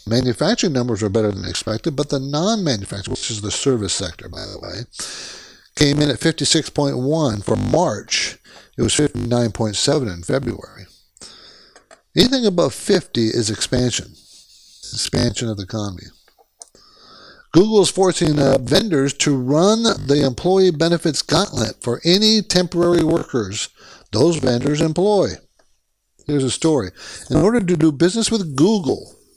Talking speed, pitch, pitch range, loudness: 135 wpm, 140 Hz, 115-170 Hz, -18 LUFS